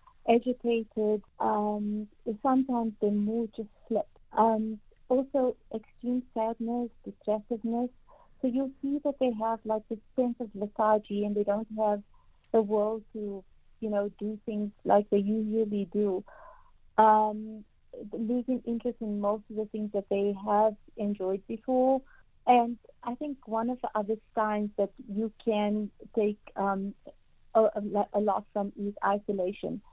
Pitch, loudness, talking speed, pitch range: 220 Hz, -30 LUFS, 140 wpm, 210-240 Hz